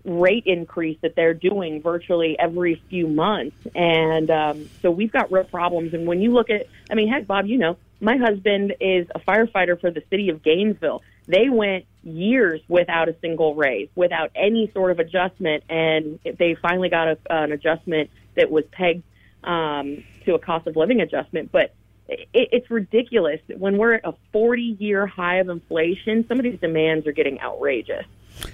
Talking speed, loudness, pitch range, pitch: 180 wpm, -21 LUFS, 160-205 Hz, 175 Hz